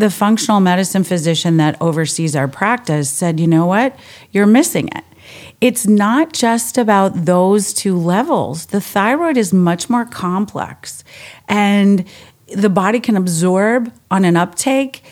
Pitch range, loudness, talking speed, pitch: 175-230 Hz, -14 LUFS, 145 wpm, 200 Hz